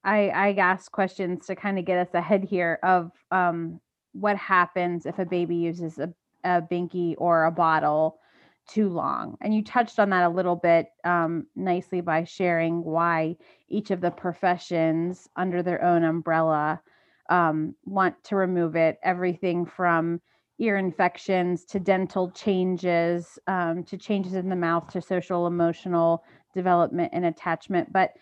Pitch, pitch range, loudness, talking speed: 175 Hz, 170-185 Hz, -25 LUFS, 155 wpm